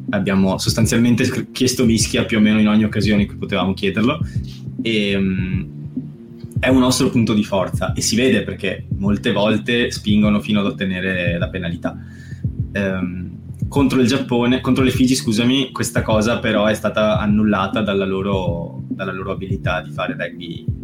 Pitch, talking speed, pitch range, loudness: 110 Hz, 160 wpm, 100-125 Hz, -18 LUFS